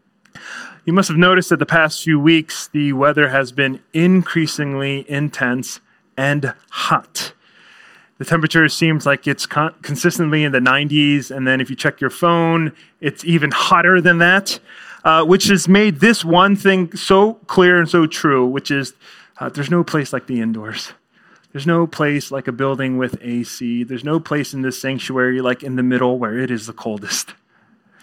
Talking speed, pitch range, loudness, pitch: 180 wpm, 130-170 Hz, -16 LUFS, 145 Hz